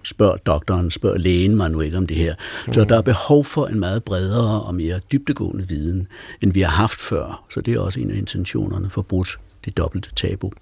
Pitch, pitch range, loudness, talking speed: 95 Hz, 90-110 Hz, -20 LUFS, 225 wpm